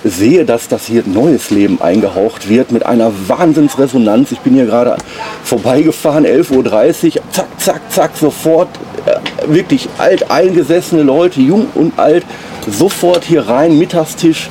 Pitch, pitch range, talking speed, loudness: 160 Hz, 125-180 Hz, 140 wpm, -11 LUFS